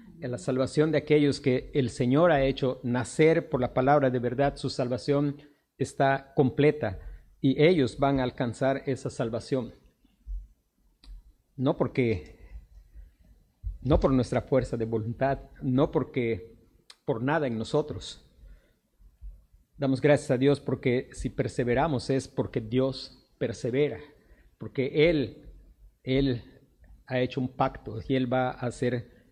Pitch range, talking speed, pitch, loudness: 120-140 Hz, 130 wpm, 130 Hz, -27 LUFS